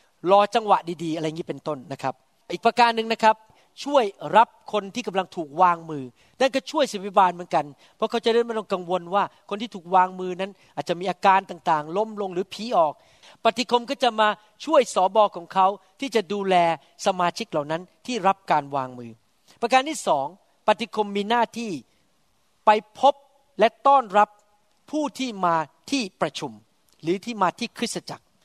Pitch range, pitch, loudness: 175-230 Hz, 200 Hz, -23 LUFS